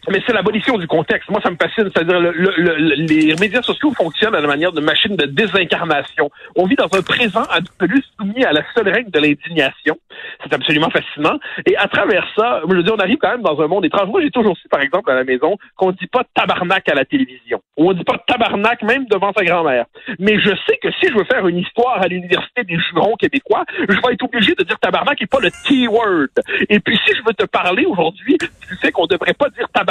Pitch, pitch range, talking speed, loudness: 215 Hz, 180-255 Hz, 245 wpm, -15 LUFS